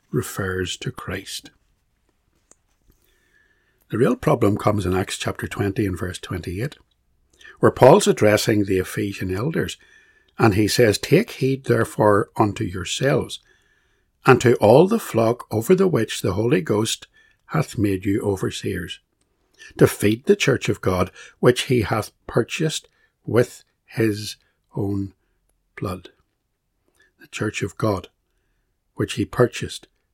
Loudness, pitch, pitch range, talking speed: -21 LUFS, 105 Hz, 95-125 Hz, 130 wpm